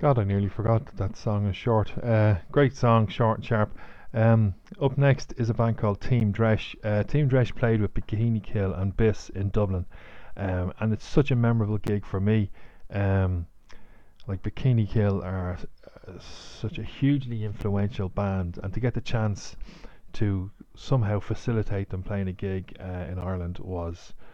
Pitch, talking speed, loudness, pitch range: 105 Hz, 175 wpm, -27 LUFS, 95-115 Hz